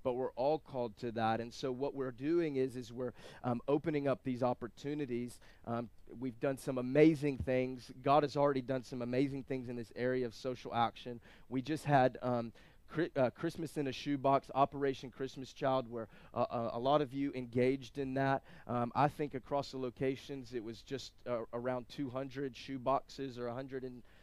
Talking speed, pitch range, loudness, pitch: 190 wpm, 120-140 Hz, -37 LUFS, 130 Hz